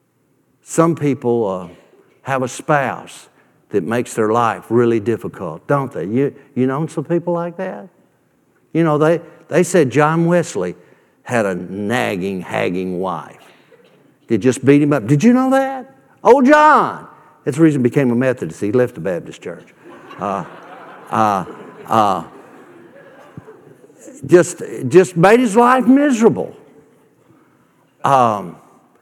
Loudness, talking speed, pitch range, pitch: -16 LUFS, 135 wpm, 115-175 Hz, 145 Hz